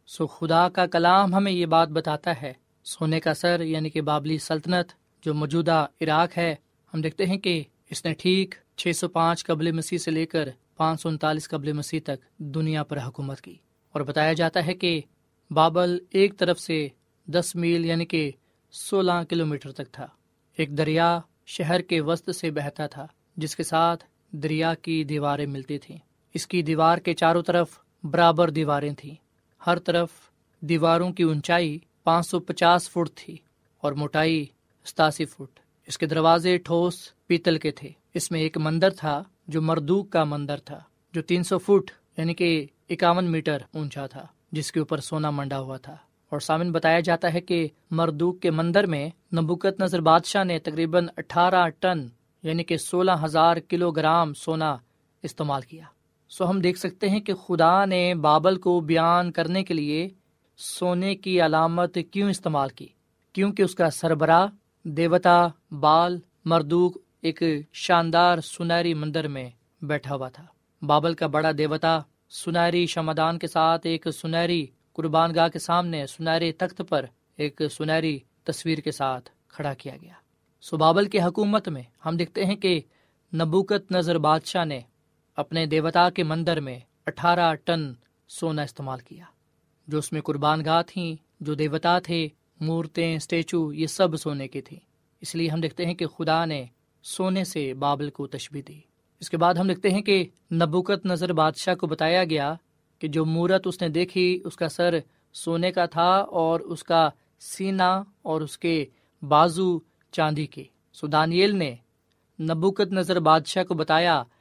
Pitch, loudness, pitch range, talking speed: 165 Hz, -24 LUFS, 155-175 Hz, 165 wpm